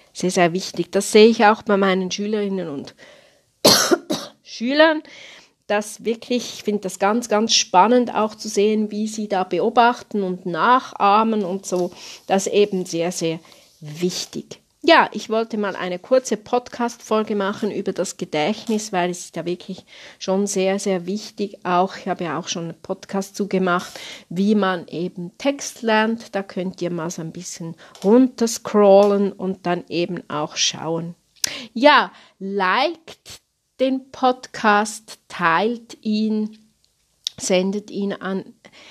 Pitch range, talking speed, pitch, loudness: 180-220 Hz, 145 wpm, 200 Hz, -20 LUFS